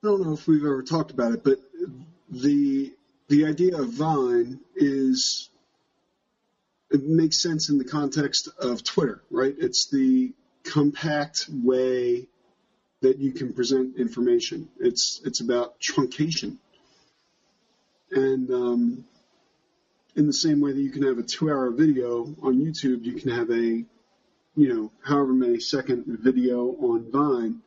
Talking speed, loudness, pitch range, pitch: 145 wpm, -24 LUFS, 130-175 Hz, 145 Hz